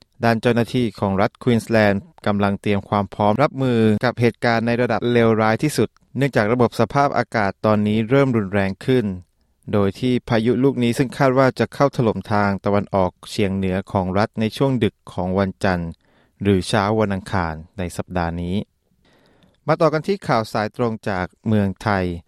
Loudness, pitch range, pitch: -20 LUFS, 100-120 Hz, 110 Hz